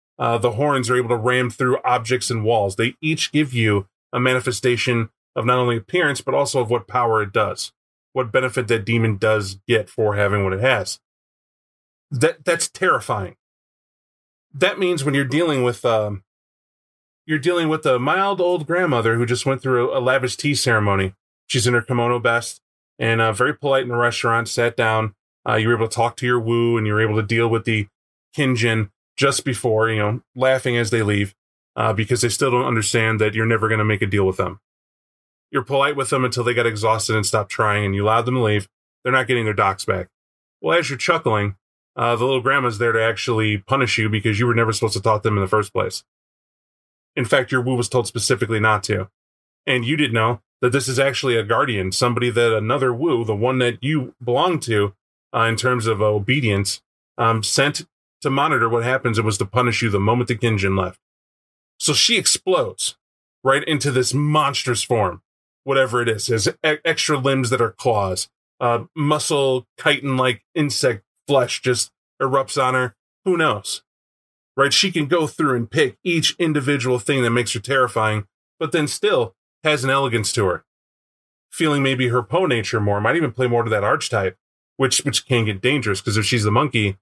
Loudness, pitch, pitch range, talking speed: -19 LUFS, 120 Hz, 110-130 Hz, 205 wpm